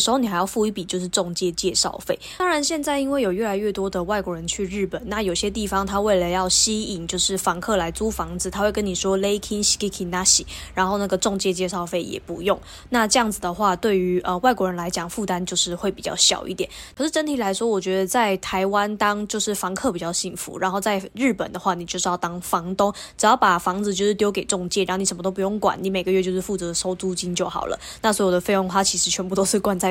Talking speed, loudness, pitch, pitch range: 375 characters per minute, -22 LUFS, 195 Hz, 185-210 Hz